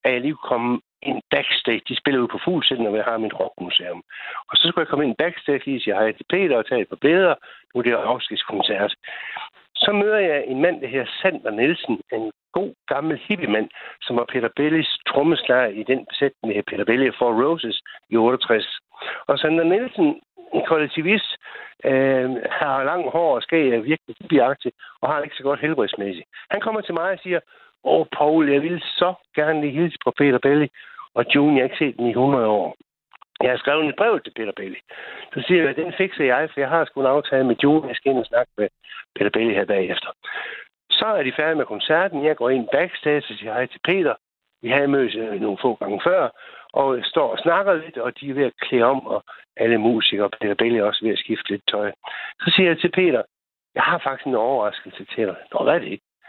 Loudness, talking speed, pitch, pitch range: -21 LUFS, 225 wpm, 145 Hz, 125-175 Hz